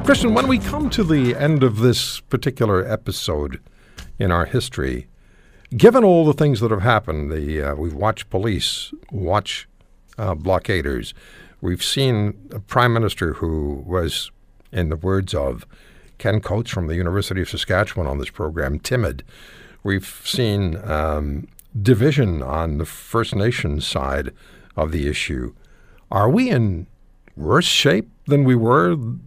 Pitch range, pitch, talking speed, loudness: 80-125 Hz, 100 Hz, 145 wpm, -20 LUFS